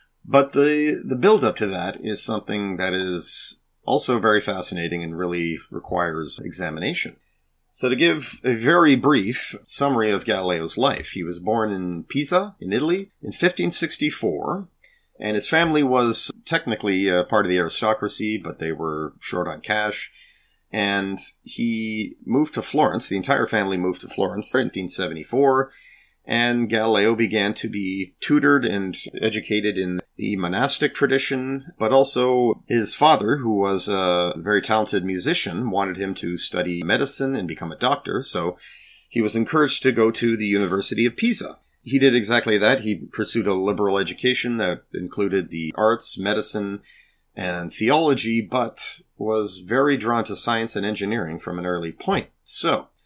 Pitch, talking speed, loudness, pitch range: 110 Hz, 155 wpm, -22 LUFS, 95-125 Hz